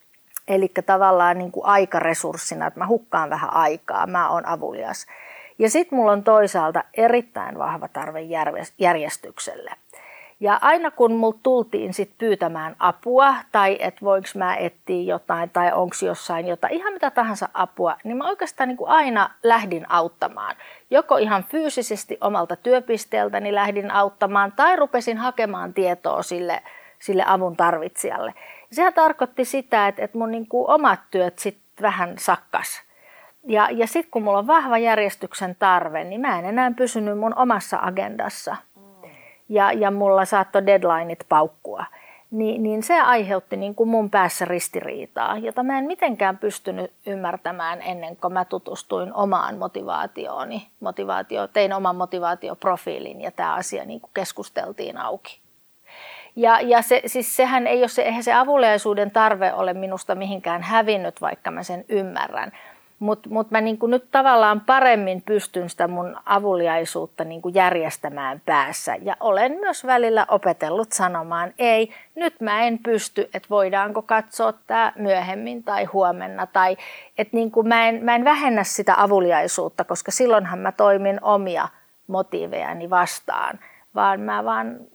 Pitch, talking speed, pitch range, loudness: 205 Hz, 140 wpm, 180-235 Hz, -21 LUFS